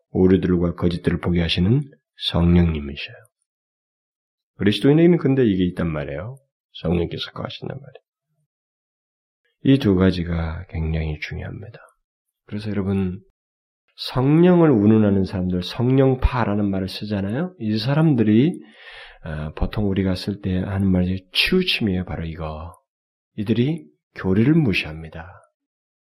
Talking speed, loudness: 290 characters per minute, -20 LUFS